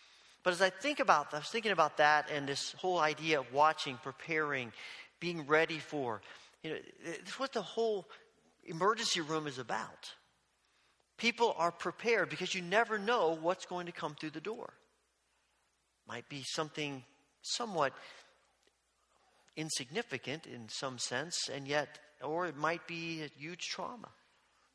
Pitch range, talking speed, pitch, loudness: 150-185 Hz, 145 wpm, 160 Hz, -35 LUFS